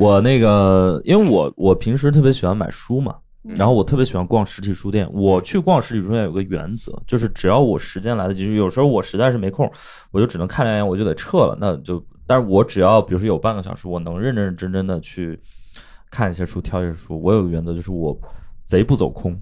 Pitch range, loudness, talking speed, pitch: 90-115 Hz, -18 LUFS, 350 characters per minute, 100 Hz